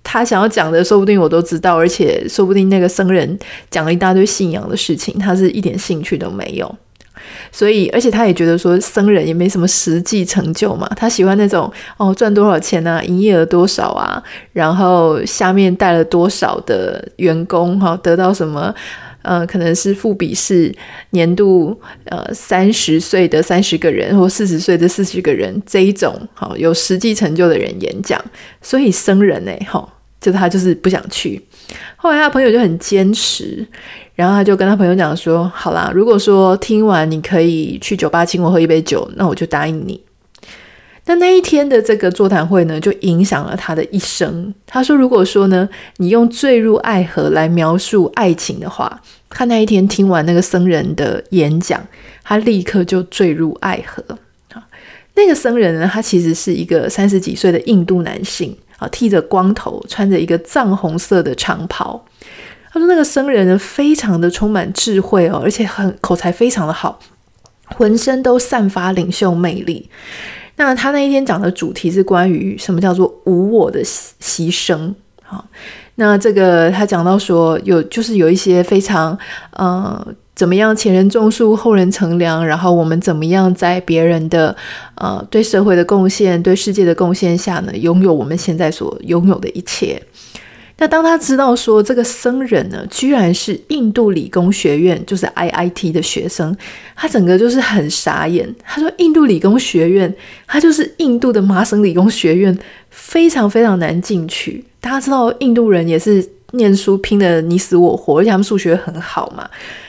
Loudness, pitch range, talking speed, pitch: -13 LUFS, 175-215 Hz, 275 characters per minute, 190 Hz